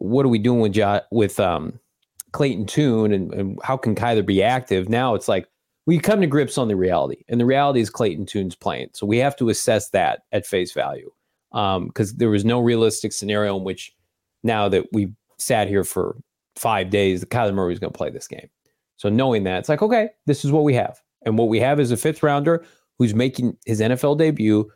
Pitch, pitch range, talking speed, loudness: 115 Hz, 100-135 Hz, 225 wpm, -21 LUFS